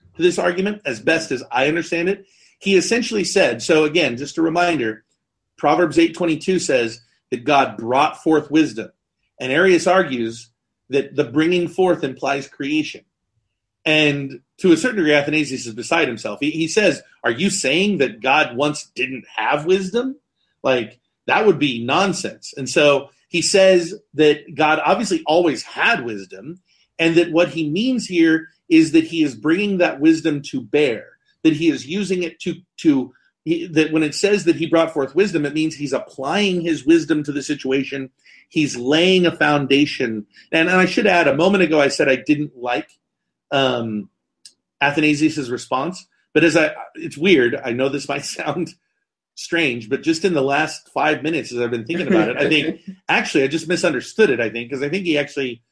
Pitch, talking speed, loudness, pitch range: 160 Hz, 180 wpm, -18 LUFS, 140-185 Hz